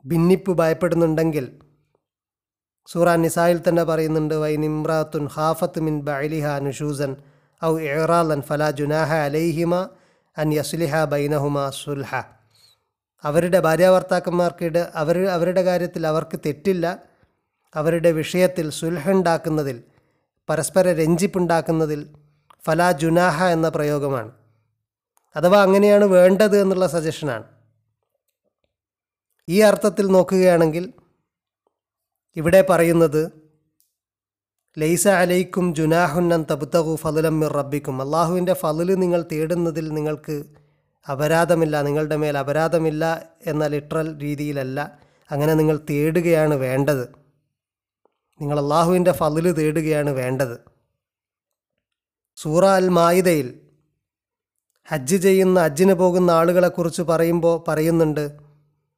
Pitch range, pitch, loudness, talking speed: 150-175 Hz, 160 Hz, -20 LUFS, 90 wpm